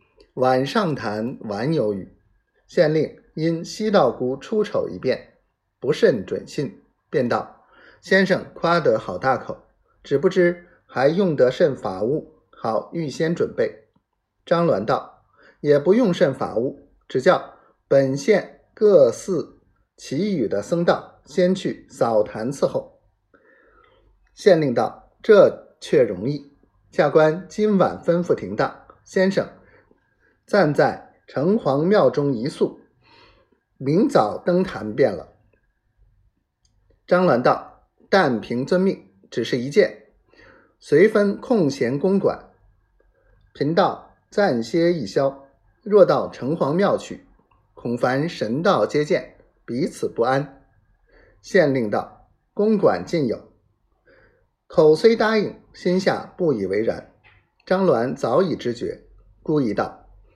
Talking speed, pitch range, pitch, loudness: 165 characters per minute, 130-215 Hz, 175 Hz, -21 LUFS